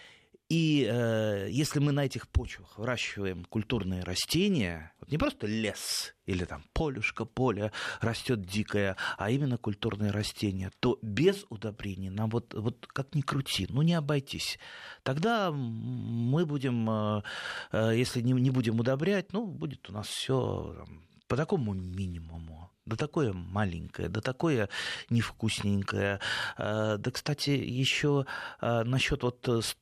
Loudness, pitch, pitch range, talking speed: -31 LUFS, 115 Hz, 100-135 Hz, 135 wpm